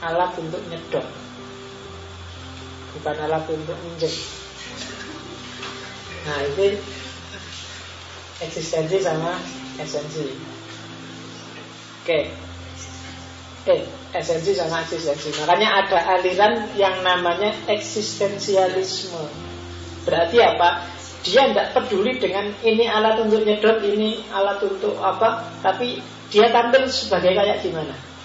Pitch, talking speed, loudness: 170 Hz, 95 wpm, -21 LUFS